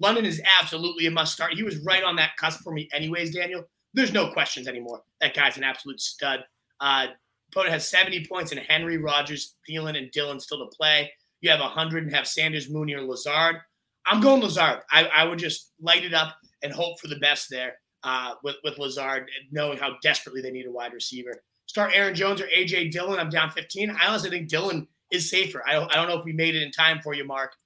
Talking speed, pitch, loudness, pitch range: 230 wpm, 155 Hz, -23 LUFS, 140-175 Hz